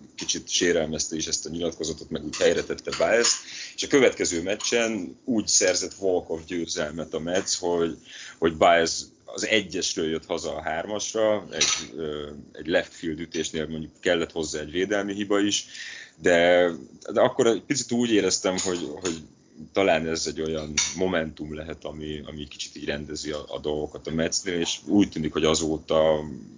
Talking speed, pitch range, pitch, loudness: 155 wpm, 75-100 Hz, 80 Hz, -25 LUFS